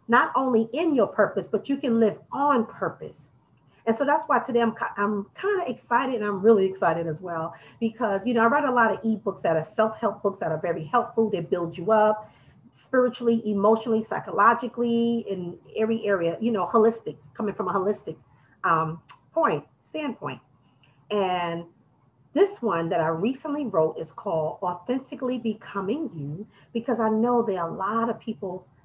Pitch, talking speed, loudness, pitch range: 215 Hz, 180 wpm, -25 LUFS, 175-235 Hz